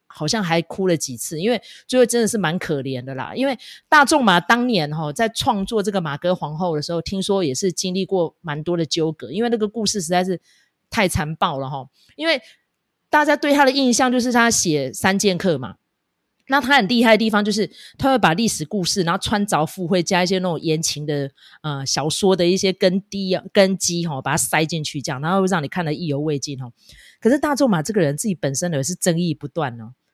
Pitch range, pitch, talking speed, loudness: 155-220 Hz, 180 Hz, 325 characters per minute, -20 LUFS